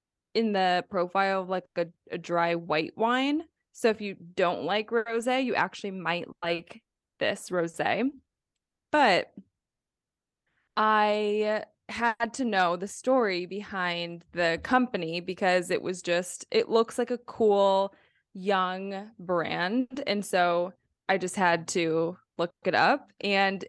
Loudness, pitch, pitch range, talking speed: -28 LUFS, 195 Hz, 175-220 Hz, 135 wpm